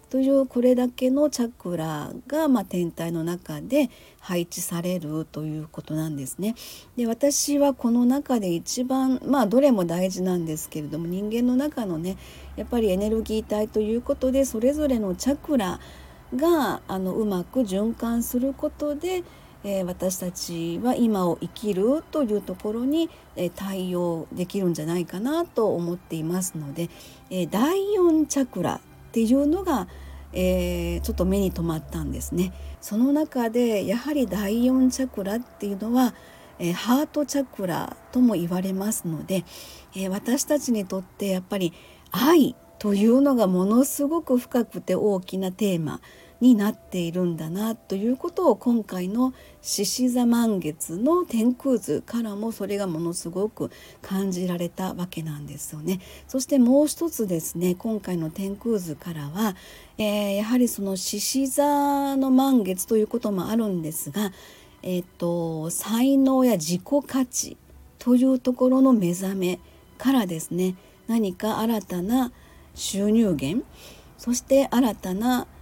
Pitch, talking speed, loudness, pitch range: 210 Hz, 300 characters per minute, -24 LUFS, 180-255 Hz